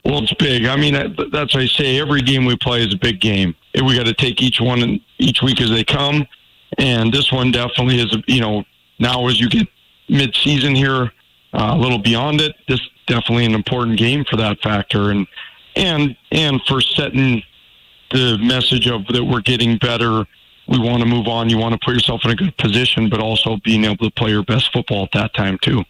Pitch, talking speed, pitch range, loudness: 120 Hz, 220 wpm, 110-130 Hz, -16 LUFS